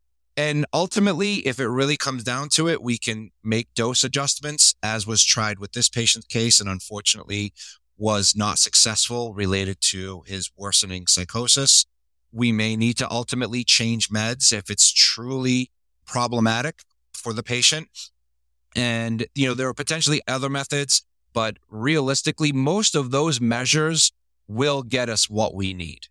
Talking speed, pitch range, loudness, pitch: 150 wpm, 105-135 Hz, -20 LUFS, 115 Hz